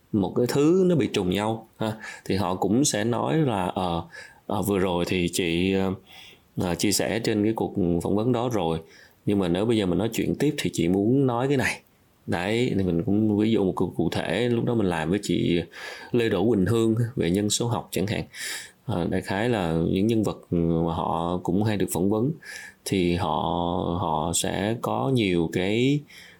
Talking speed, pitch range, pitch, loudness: 205 wpm, 90-115 Hz, 100 Hz, -25 LUFS